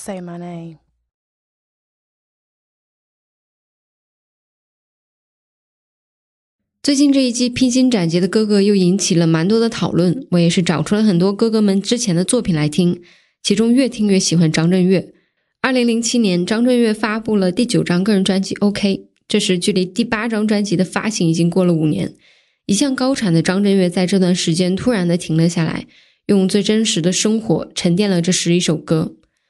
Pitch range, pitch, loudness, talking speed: 175-220 Hz, 190 Hz, -16 LUFS, 250 characters per minute